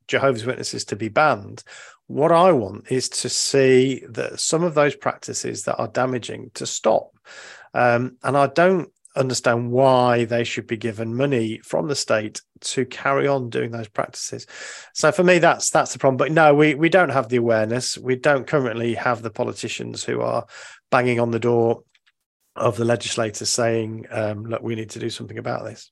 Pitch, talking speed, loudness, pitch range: 125 Hz, 190 wpm, -21 LUFS, 115-135 Hz